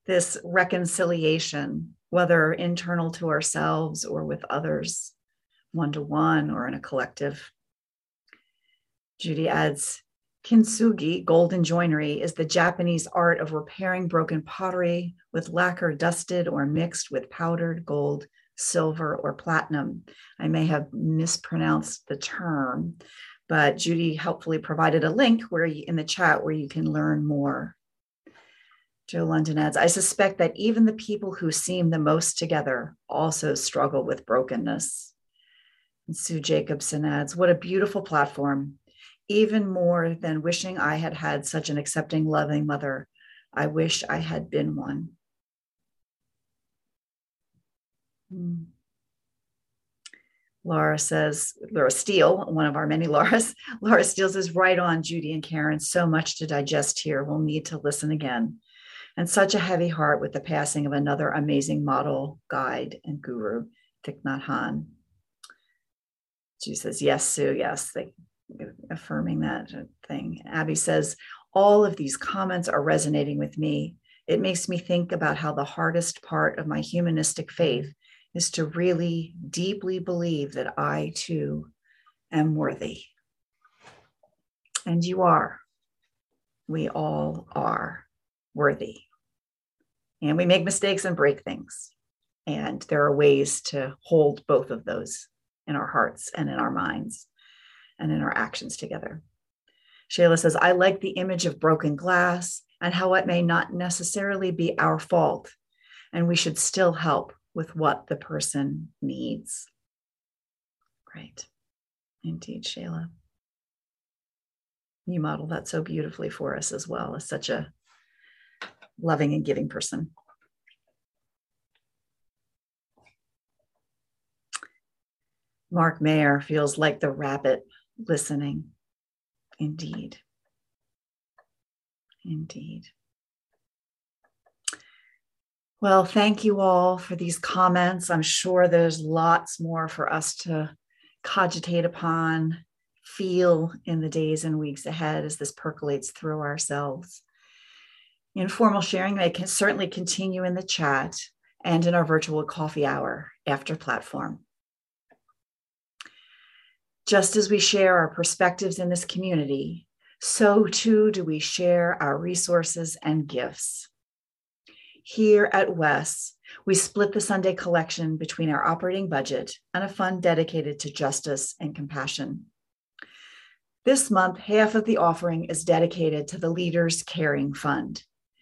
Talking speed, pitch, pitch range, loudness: 130 wpm, 165 Hz, 150-180 Hz, -25 LUFS